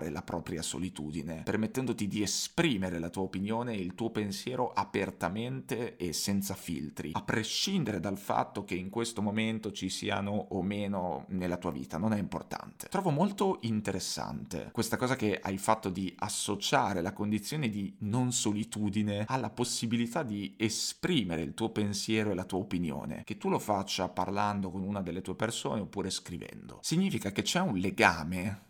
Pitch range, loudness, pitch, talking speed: 95-110 Hz, -33 LUFS, 105 Hz, 165 wpm